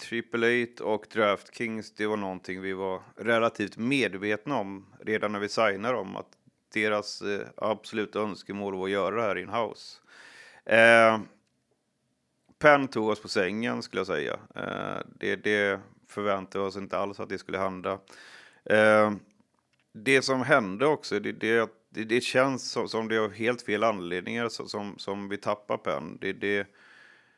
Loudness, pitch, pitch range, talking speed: -27 LUFS, 105 Hz, 100-115 Hz, 165 wpm